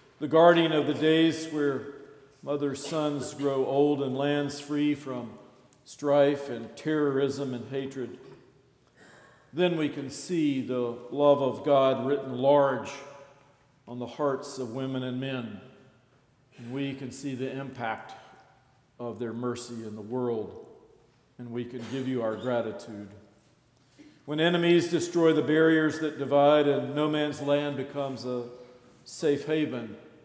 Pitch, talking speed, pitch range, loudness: 140 Hz, 135 wpm, 125-145 Hz, -27 LUFS